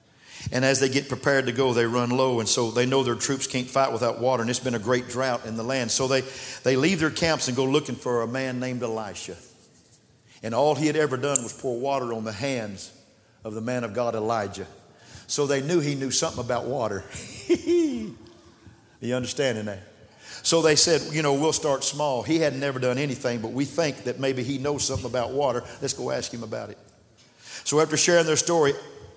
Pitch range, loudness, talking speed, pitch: 115-145 Hz, -24 LUFS, 220 wpm, 130 Hz